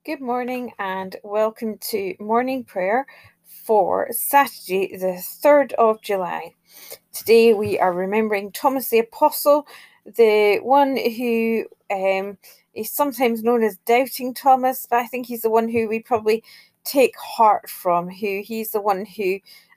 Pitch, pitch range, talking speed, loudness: 225 Hz, 205-250 Hz, 145 wpm, -20 LUFS